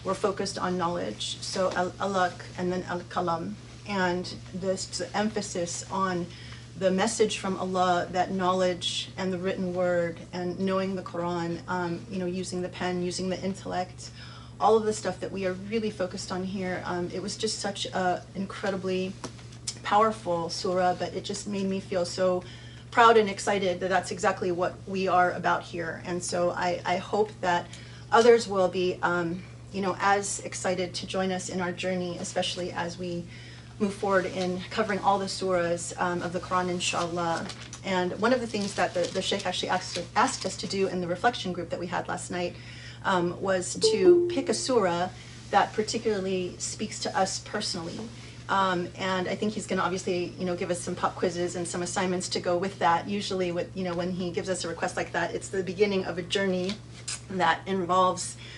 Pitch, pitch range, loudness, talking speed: 180 Hz, 175-190 Hz, -28 LUFS, 190 wpm